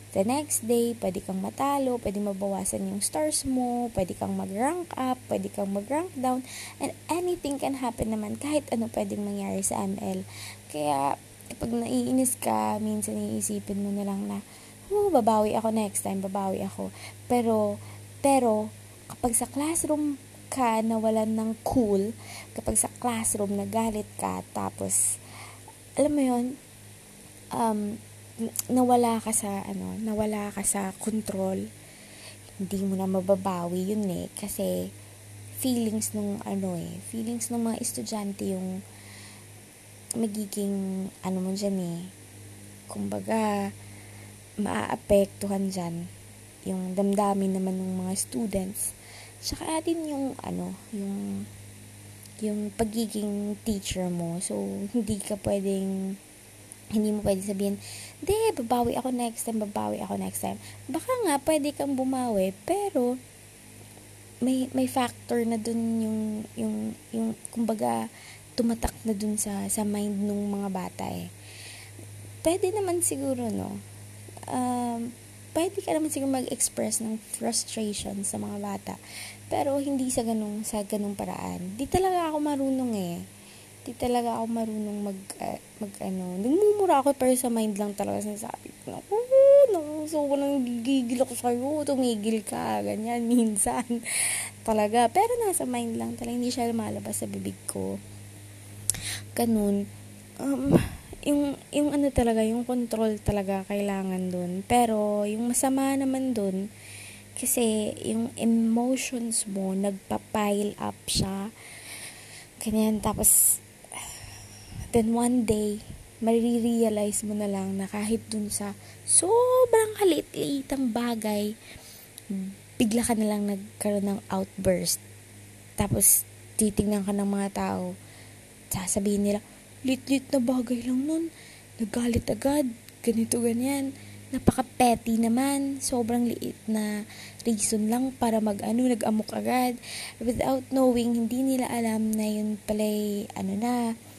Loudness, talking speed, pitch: -27 LUFS, 125 wpm, 210 Hz